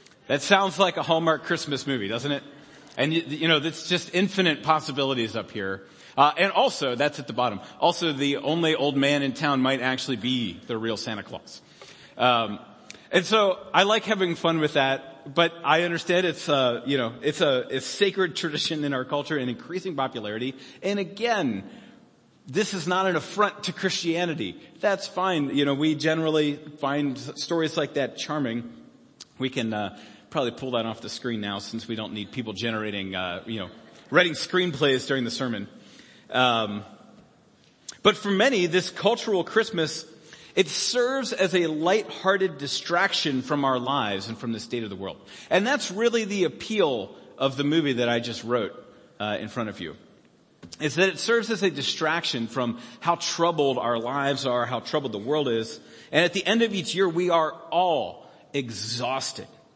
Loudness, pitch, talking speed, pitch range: -25 LUFS, 145 Hz, 180 wpm, 125-175 Hz